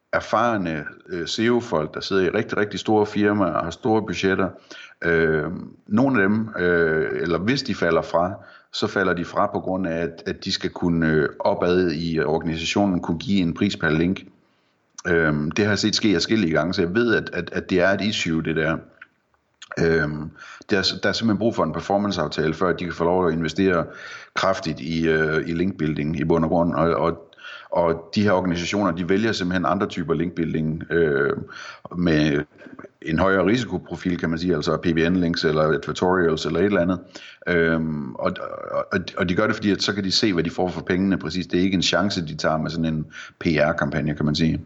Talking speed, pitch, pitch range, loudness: 190 wpm, 85 Hz, 80-95 Hz, -22 LUFS